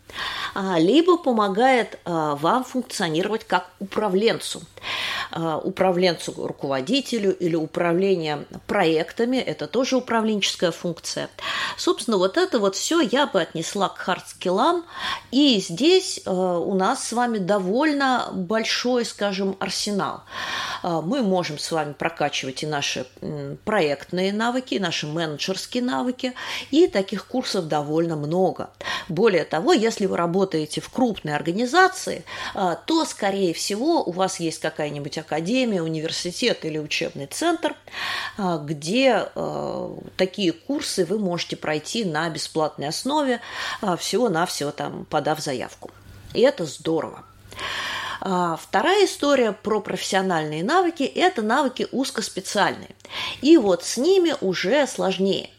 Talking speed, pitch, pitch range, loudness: 120 wpm, 190 Hz, 170-255 Hz, -23 LUFS